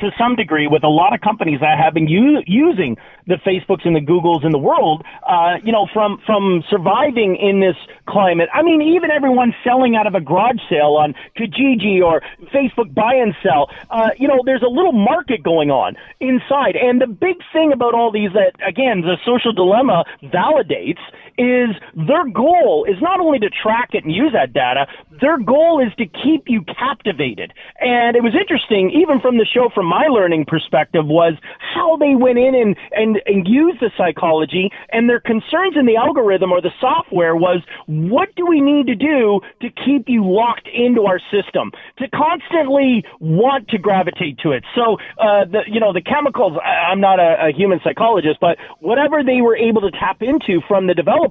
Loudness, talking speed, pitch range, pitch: -15 LUFS, 195 wpm, 185-265 Hz, 225 Hz